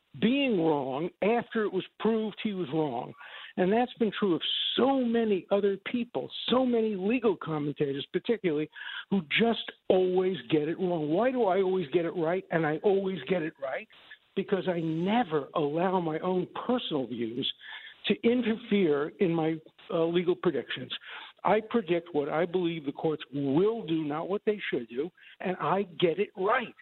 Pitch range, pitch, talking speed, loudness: 160-215 Hz, 185 Hz, 170 wpm, -29 LUFS